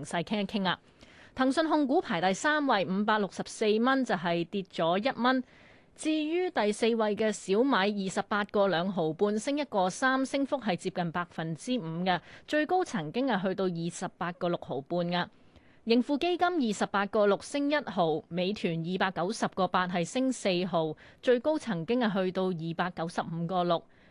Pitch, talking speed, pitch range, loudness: 200 Hz, 265 characters per minute, 180-250 Hz, -30 LUFS